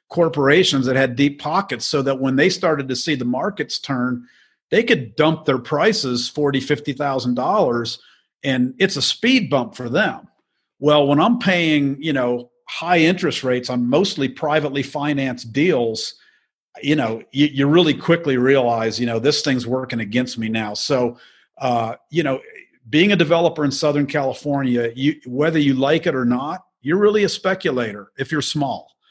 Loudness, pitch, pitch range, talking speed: -19 LUFS, 140 Hz, 125-155 Hz, 175 wpm